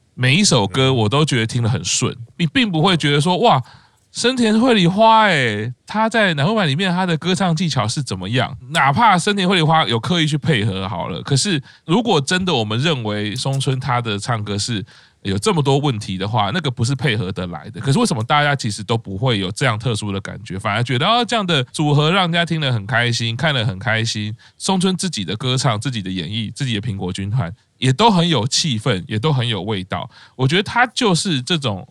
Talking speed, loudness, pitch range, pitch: 330 characters per minute, -18 LUFS, 110-165 Hz, 130 Hz